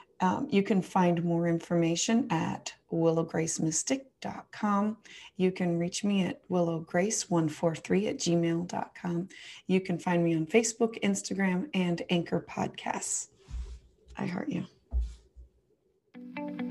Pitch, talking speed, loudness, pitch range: 175 Hz, 105 wpm, -30 LUFS, 165-205 Hz